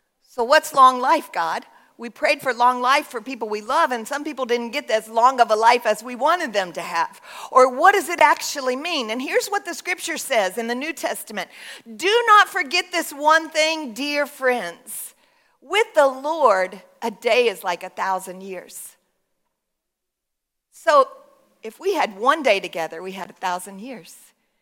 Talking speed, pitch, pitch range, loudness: 185 wpm, 260 Hz, 225-315 Hz, -20 LUFS